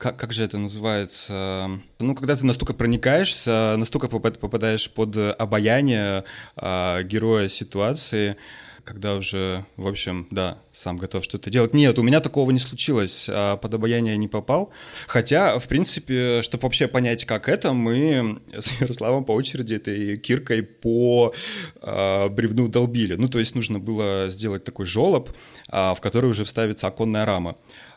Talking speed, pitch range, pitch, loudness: 145 wpm, 100-125 Hz, 110 Hz, -22 LUFS